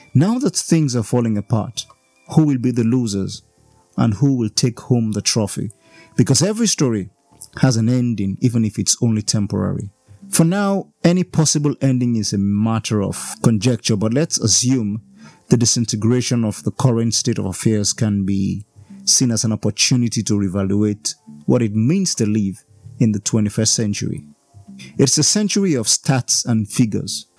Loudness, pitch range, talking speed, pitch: -18 LUFS, 105-130 Hz, 160 wpm, 115 Hz